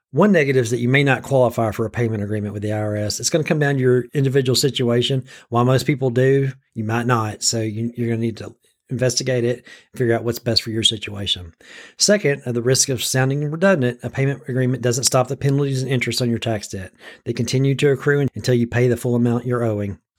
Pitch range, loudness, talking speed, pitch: 115-135 Hz, -19 LUFS, 235 wpm, 125 Hz